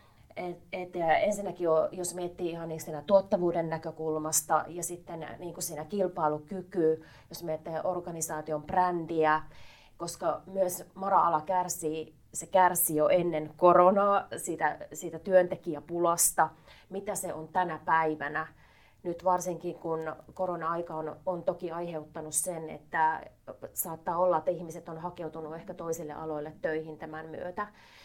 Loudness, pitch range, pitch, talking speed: -30 LUFS, 155-180 Hz, 165 Hz, 130 wpm